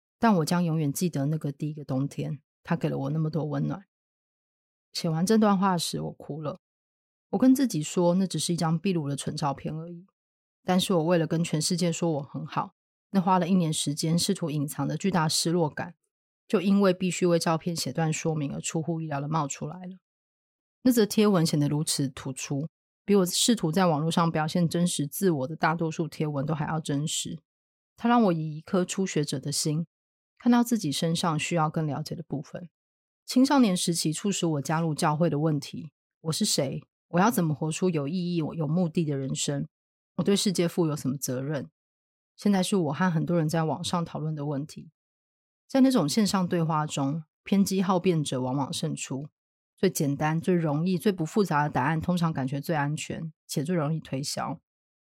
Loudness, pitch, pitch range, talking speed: -27 LUFS, 165 Hz, 150-185 Hz, 285 characters per minute